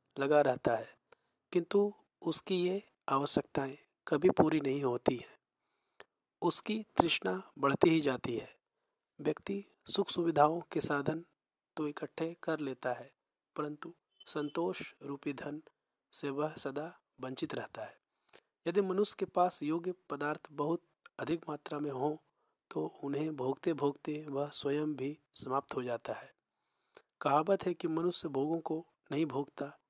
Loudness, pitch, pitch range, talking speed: -35 LUFS, 150 Hz, 140-170 Hz, 135 wpm